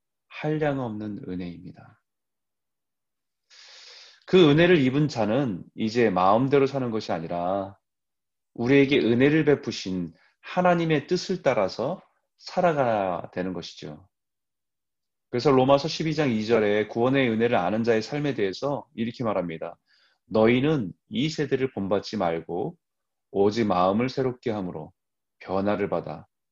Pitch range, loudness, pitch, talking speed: 100-140 Hz, -24 LUFS, 115 Hz, 265 characters per minute